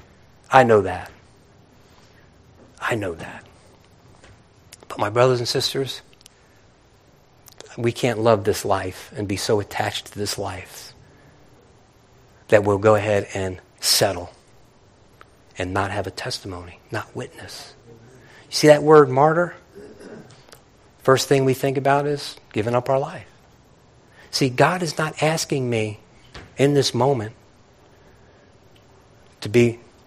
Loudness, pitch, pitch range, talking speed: -20 LUFS, 120 Hz, 100-135 Hz, 125 wpm